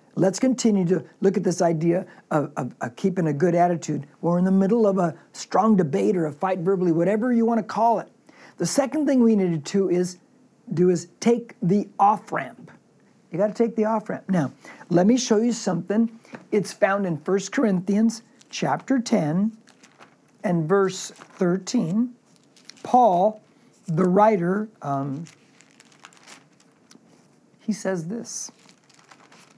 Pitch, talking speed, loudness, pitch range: 200 Hz, 145 wpm, -23 LUFS, 180-225 Hz